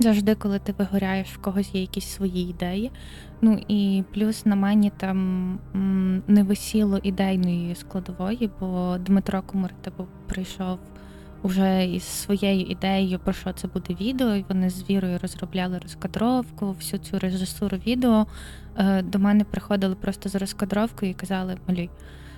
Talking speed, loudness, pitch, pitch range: 140 wpm, -25 LUFS, 195 Hz, 185-205 Hz